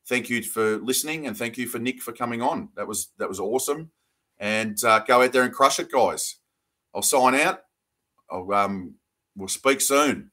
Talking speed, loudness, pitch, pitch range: 200 wpm, -23 LUFS, 120 Hz, 110-130 Hz